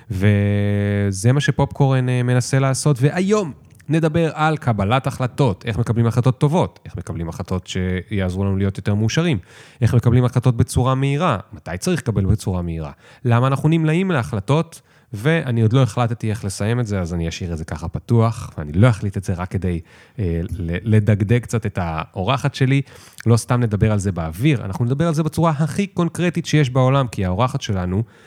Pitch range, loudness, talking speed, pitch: 100-140 Hz, -19 LUFS, 175 wpm, 120 Hz